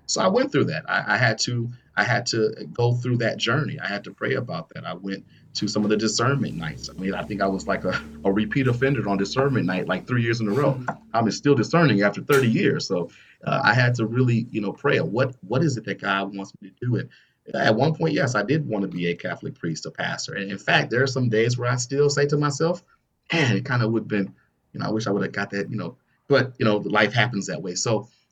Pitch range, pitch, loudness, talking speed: 100-135 Hz, 115 Hz, -23 LUFS, 275 wpm